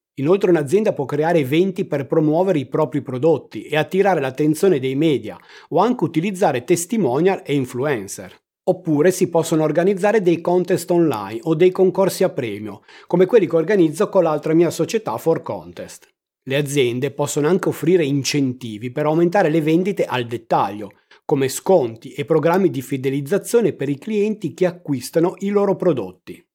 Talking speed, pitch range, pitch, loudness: 155 wpm, 145-185 Hz, 165 Hz, -19 LUFS